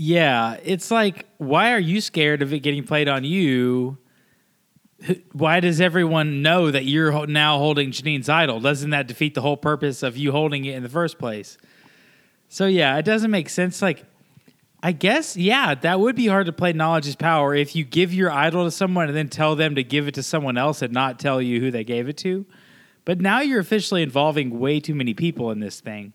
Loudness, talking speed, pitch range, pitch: -21 LUFS, 215 wpm, 140-180 Hz, 155 Hz